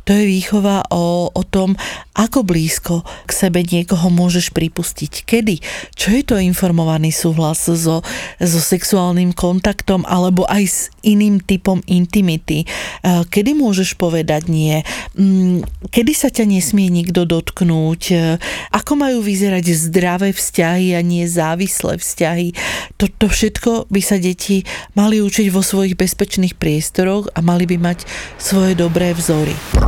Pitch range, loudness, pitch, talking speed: 170-200 Hz, -15 LUFS, 185 Hz, 130 wpm